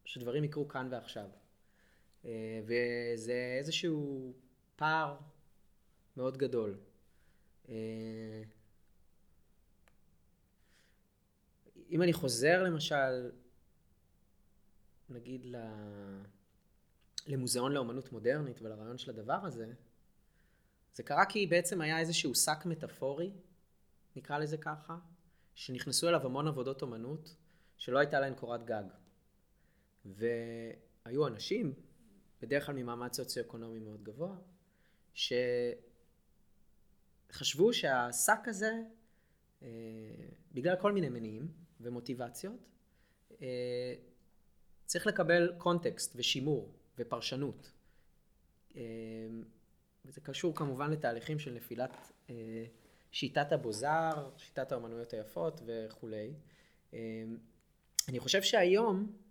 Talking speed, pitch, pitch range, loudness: 80 wpm, 130 Hz, 115-160 Hz, -36 LUFS